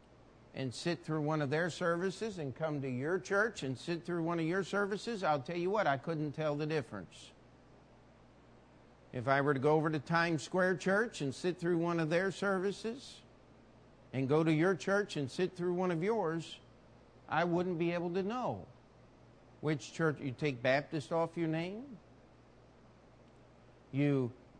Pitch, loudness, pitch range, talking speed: 160 Hz, -35 LUFS, 140-180 Hz, 175 wpm